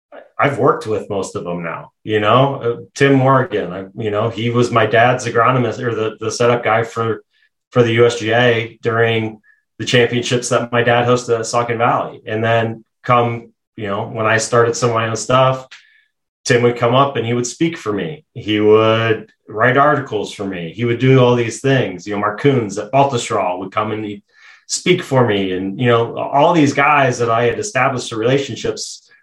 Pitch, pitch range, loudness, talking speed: 120 Hz, 110-125 Hz, -16 LUFS, 200 wpm